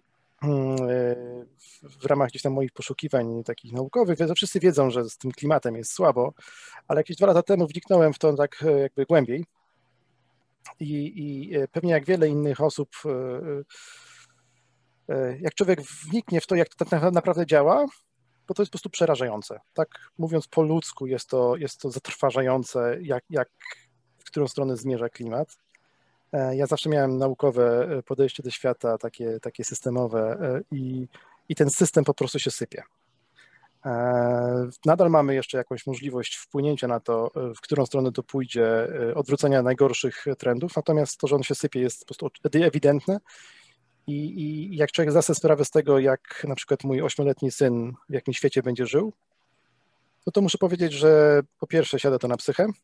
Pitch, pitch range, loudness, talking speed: 140 Hz, 125-155 Hz, -24 LUFS, 160 wpm